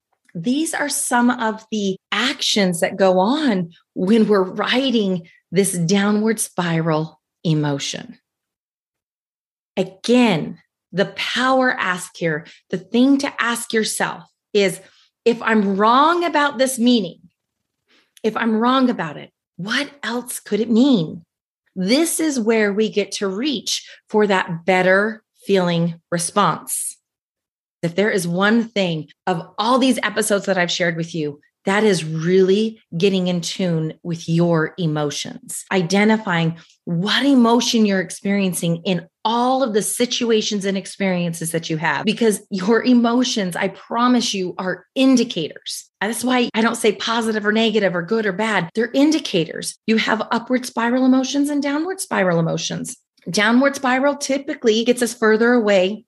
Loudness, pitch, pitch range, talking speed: -19 LUFS, 210 Hz, 185-240 Hz, 140 wpm